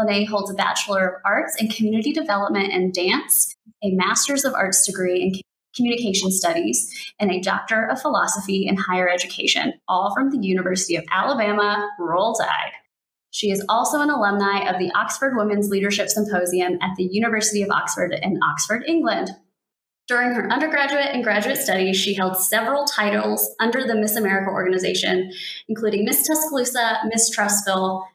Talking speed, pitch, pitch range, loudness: 160 wpm, 205 Hz, 190-235 Hz, -20 LUFS